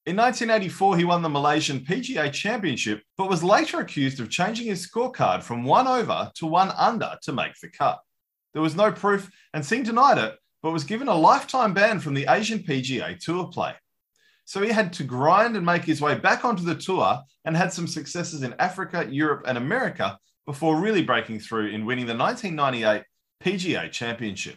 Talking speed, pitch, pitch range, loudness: 190 wpm, 170 Hz, 140-200 Hz, -24 LUFS